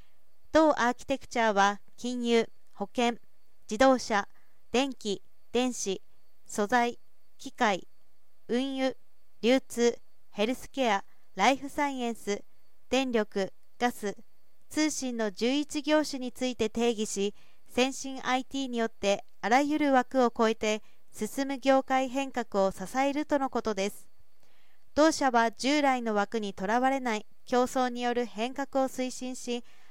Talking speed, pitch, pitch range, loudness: 235 characters per minute, 245 Hz, 220-265 Hz, -29 LUFS